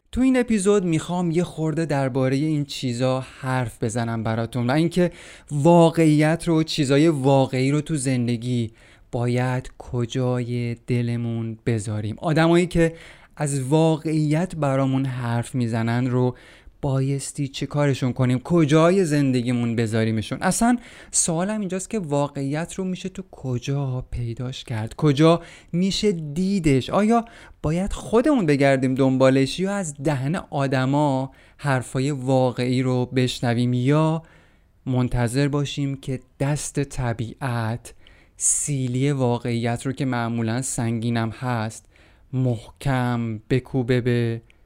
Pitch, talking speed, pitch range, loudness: 135 Hz, 110 wpm, 120-160 Hz, -22 LUFS